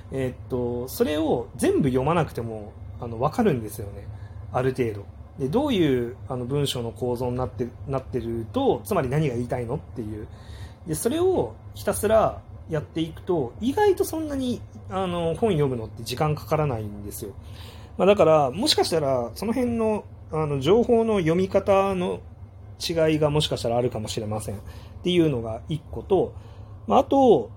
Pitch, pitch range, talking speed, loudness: 125 Hz, 105-165 Hz, 345 characters per minute, -24 LUFS